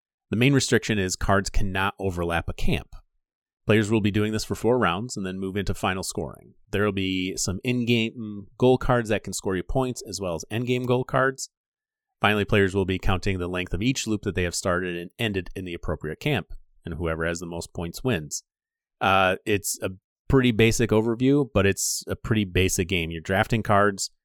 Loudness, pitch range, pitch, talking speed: -25 LUFS, 95-115 Hz, 100 Hz, 205 wpm